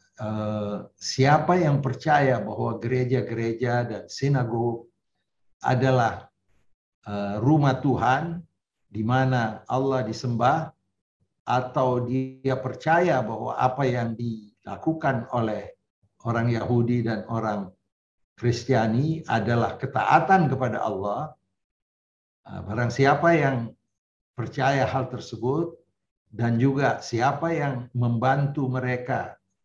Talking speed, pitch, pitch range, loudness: 85 wpm, 125 Hz, 110-135 Hz, -25 LUFS